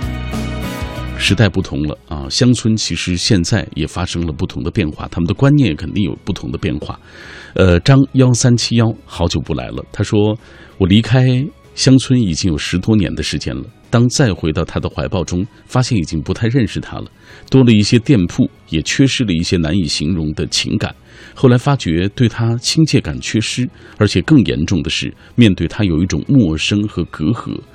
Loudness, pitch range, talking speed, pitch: -15 LUFS, 85-120 Hz, 280 characters per minute, 105 Hz